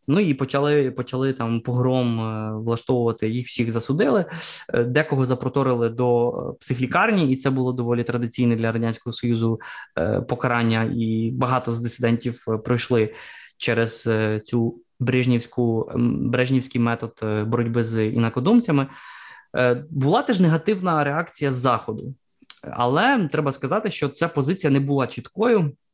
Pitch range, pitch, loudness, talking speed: 115-140 Hz, 125 Hz, -22 LUFS, 120 wpm